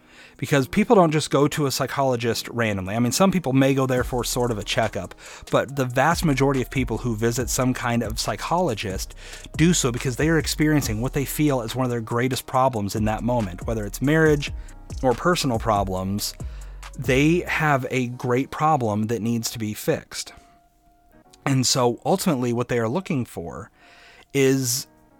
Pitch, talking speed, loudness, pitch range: 130 Hz, 180 wpm, -22 LUFS, 115-140 Hz